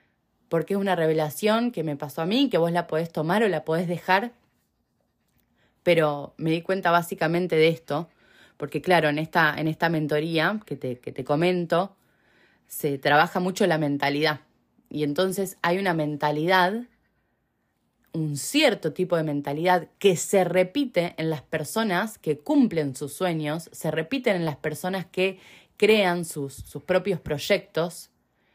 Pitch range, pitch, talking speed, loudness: 155-185 Hz, 165 Hz, 155 wpm, -24 LUFS